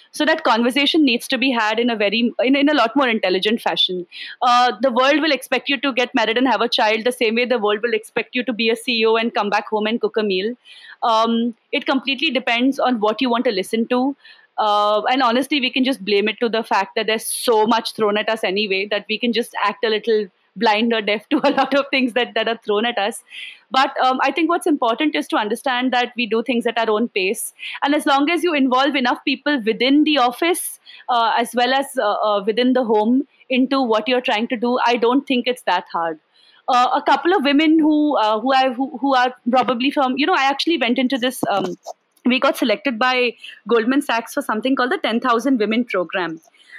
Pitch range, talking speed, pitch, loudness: 225-275 Hz, 235 wpm, 245 Hz, -18 LUFS